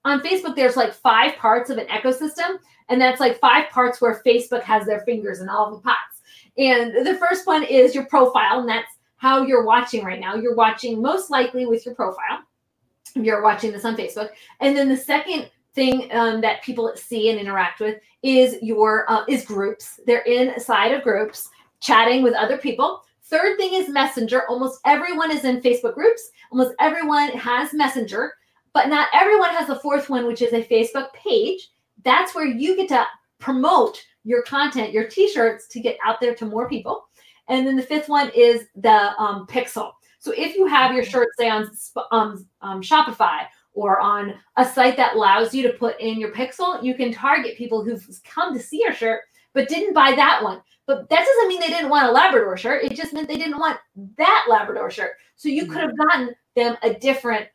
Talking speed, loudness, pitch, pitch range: 200 wpm, -19 LUFS, 250 Hz, 230-290 Hz